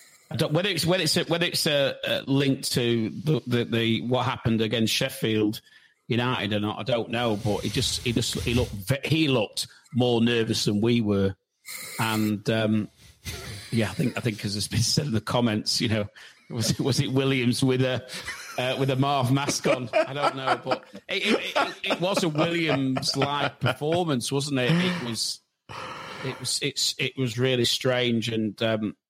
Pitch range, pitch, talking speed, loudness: 110-140 Hz, 125 Hz, 185 wpm, -25 LUFS